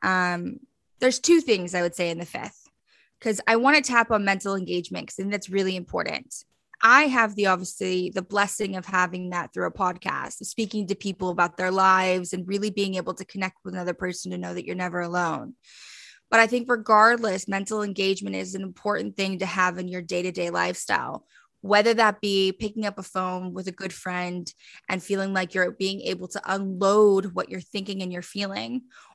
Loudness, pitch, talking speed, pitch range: -24 LUFS, 190 Hz, 200 wpm, 180-205 Hz